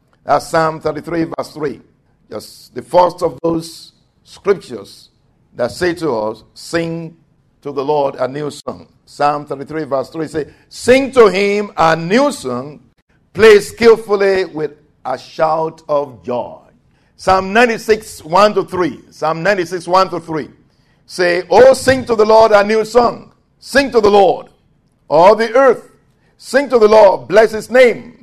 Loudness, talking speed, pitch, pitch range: -13 LUFS, 155 wpm, 170 Hz, 150-220 Hz